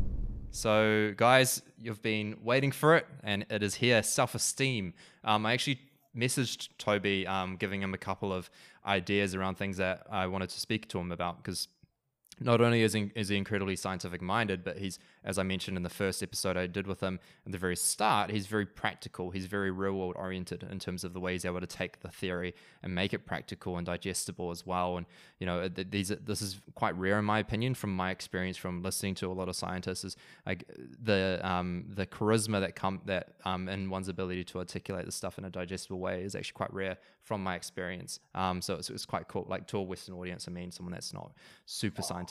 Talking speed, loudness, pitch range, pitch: 220 wpm, -33 LUFS, 90-105 Hz, 95 Hz